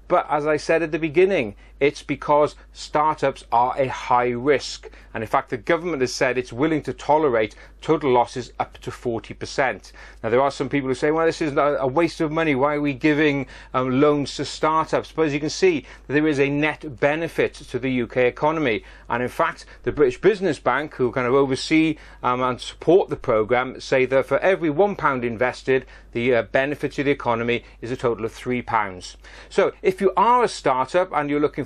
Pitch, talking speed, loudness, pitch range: 145 Hz, 205 wpm, -22 LUFS, 125-155 Hz